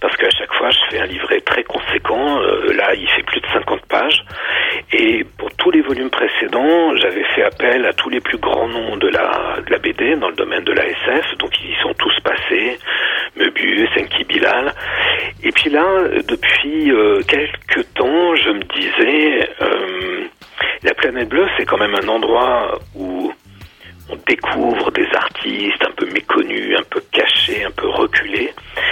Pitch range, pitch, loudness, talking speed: 315-440 Hz, 385 Hz, -15 LUFS, 180 wpm